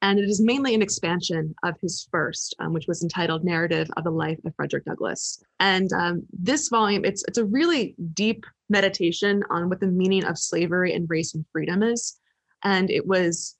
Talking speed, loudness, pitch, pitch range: 195 wpm, -24 LUFS, 185 Hz, 170-205 Hz